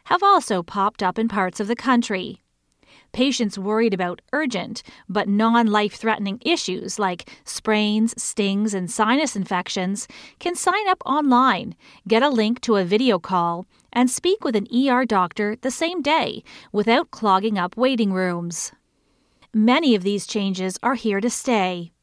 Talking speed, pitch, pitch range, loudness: 155 wpm, 220 Hz, 195-250 Hz, -21 LUFS